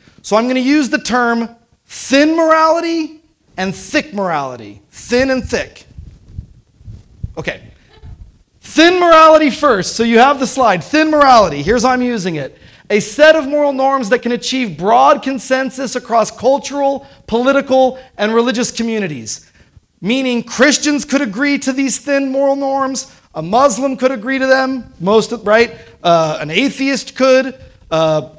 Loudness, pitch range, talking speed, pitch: -13 LUFS, 225-275 Hz, 145 wpm, 260 Hz